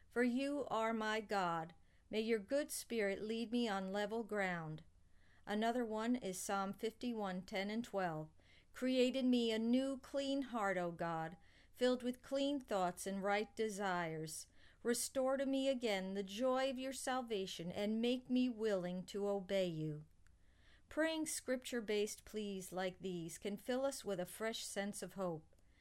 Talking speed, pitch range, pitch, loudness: 160 wpm, 185-250 Hz, 210 Hz, -41 LUFS